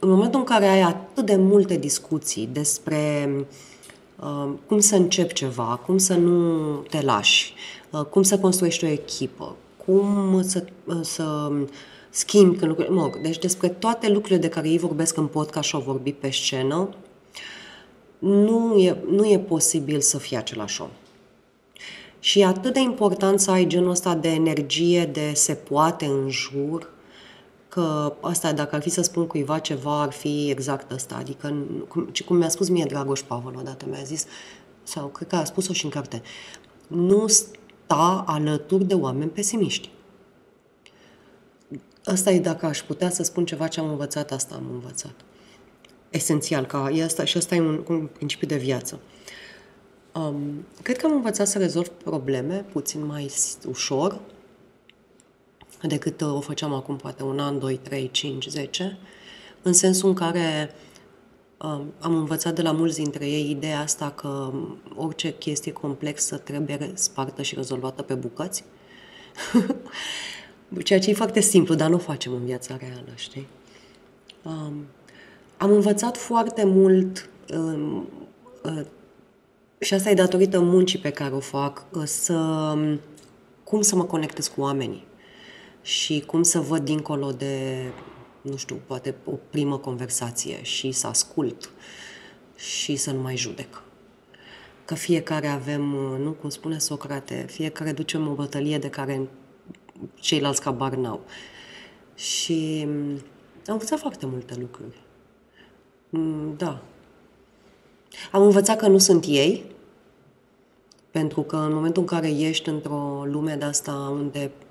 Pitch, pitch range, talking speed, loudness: 155 Hz, 140-180 Hz, 145 wpm, -23 LUFS